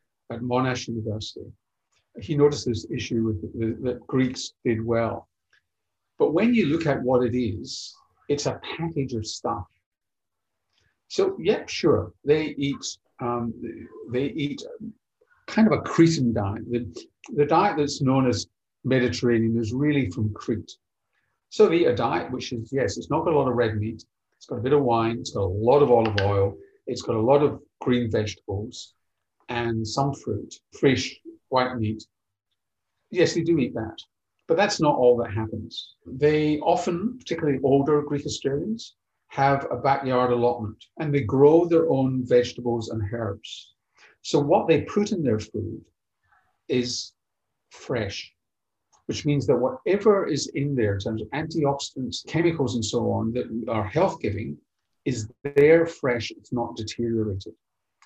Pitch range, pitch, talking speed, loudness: 115-145 Hz, 125 Hz, 160 wpm, -24 LUFS